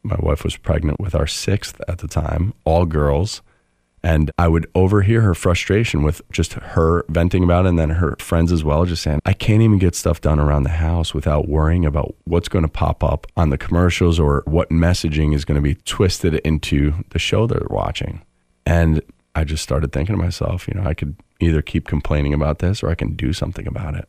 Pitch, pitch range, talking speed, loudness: 80 Hz, 75-90 Hz, 220 wpm, -19 LUFS